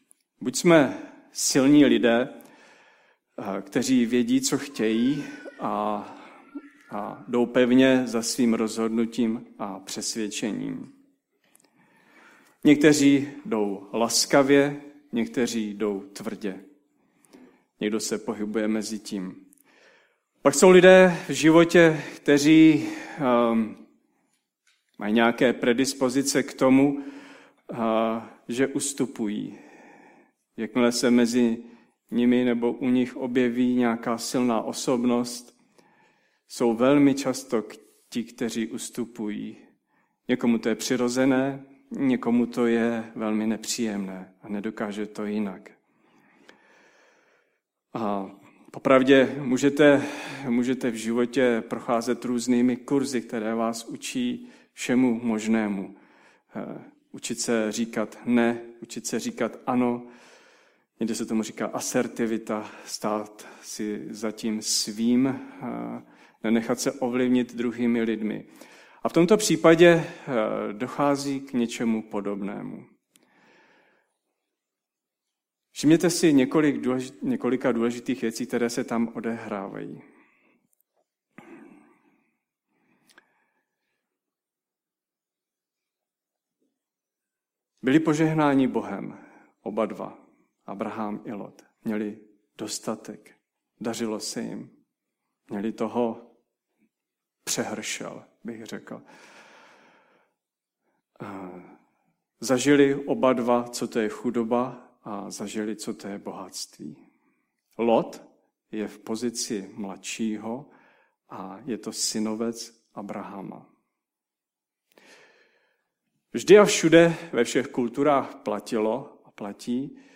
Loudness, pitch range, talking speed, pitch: -24 LUFS, 110-140 Hz, 90 wpm, 120 Hz